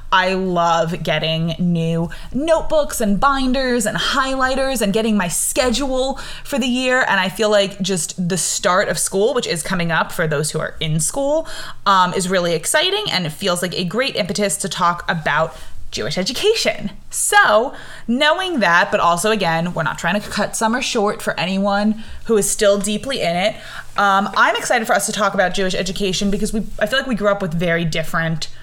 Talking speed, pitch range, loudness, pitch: 195 wpm, 175-235 Hz, -18 LUFS, 200 Hz